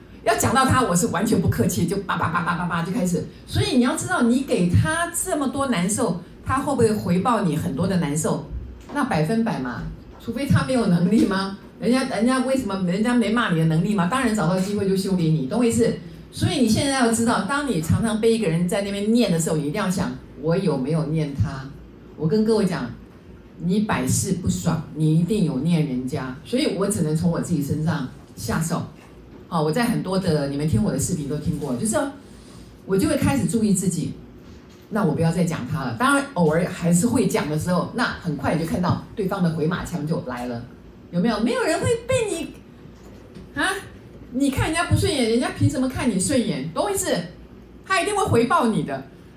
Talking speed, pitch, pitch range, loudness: 310 characters per minute, 190 Hz, 160-235 Hz, -22 LUFS